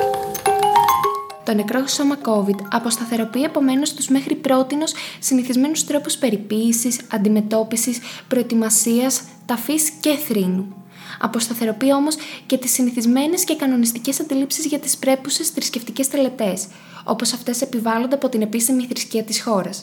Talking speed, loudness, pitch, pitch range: 120 wpm, -19 LUFS, 250 Hz, 225-280 Hz